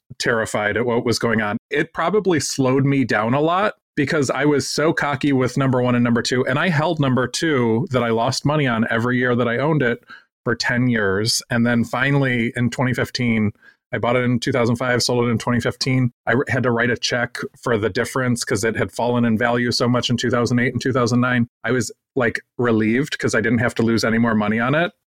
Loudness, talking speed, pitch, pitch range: -19 LUFS, 220 wpm, 120 Hz, 115-130 Hz